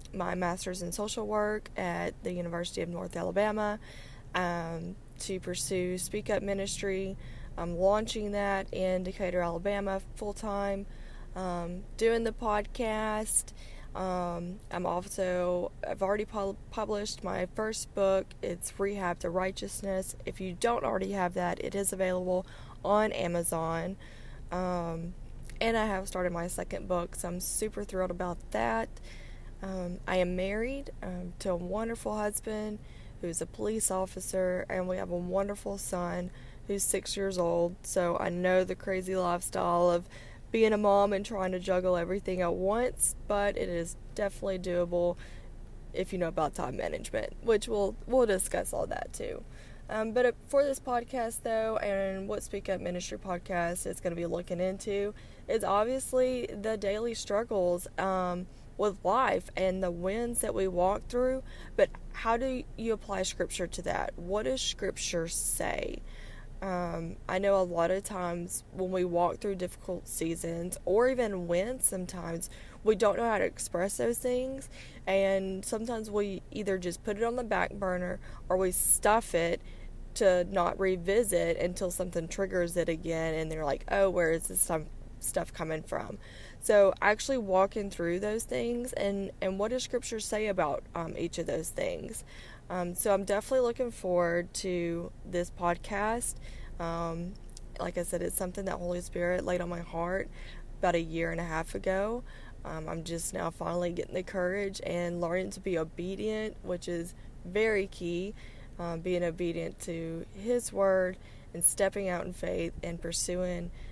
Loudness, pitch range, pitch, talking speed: -32 LUFS, 175-205 Hz, 185 Hz, 160 wpm